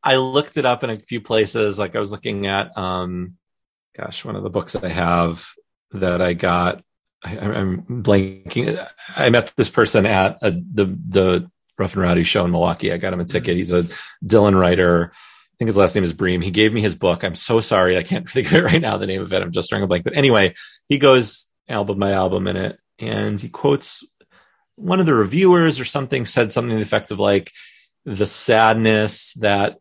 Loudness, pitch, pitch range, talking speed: -18 LUFS, 105 Hz, 90-120 Hz, 220 wpm